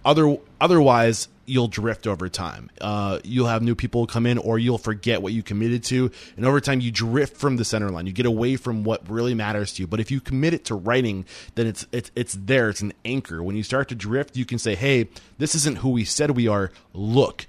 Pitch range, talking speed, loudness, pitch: 105-130 Hz, 240 wpm, -23 LUFS, 115 Hz